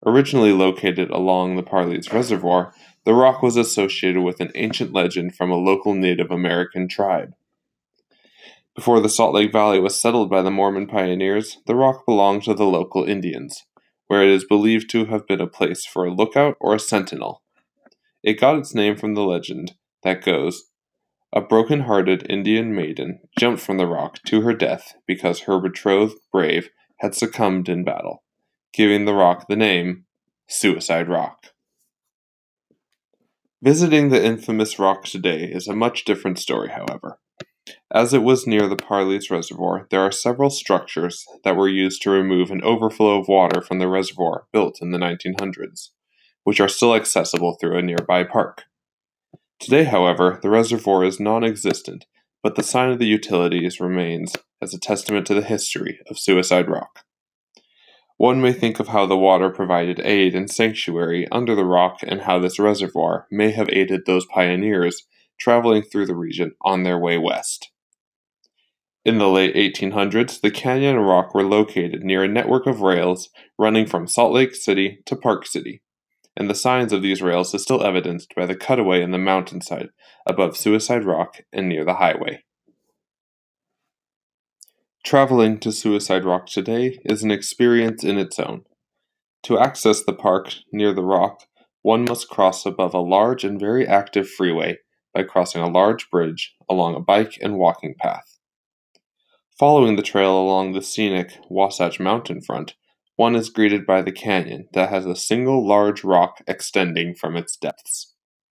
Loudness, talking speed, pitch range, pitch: -19 LUFS, 165 wpm, 90-110 Hz, 100 Hz